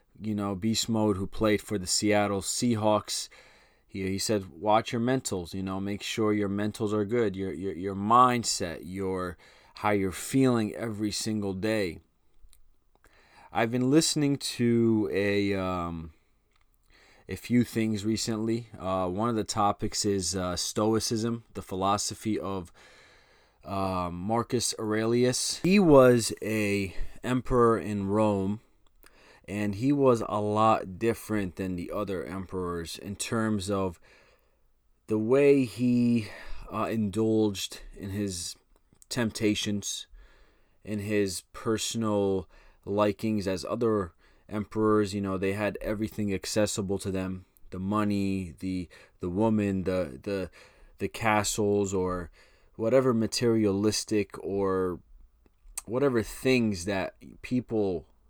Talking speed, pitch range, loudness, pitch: 120 wpm, 95-110 Hz, -28 LUFS, 105 Hz